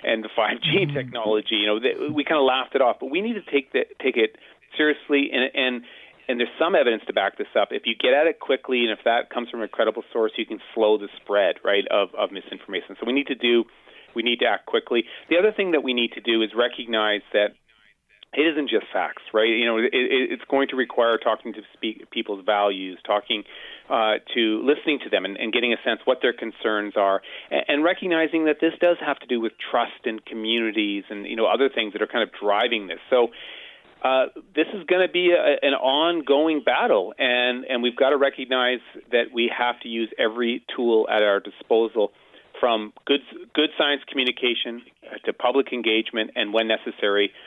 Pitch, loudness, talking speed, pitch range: 120 Hz, -23 LUFS, 215 wpm, 110-145 Hz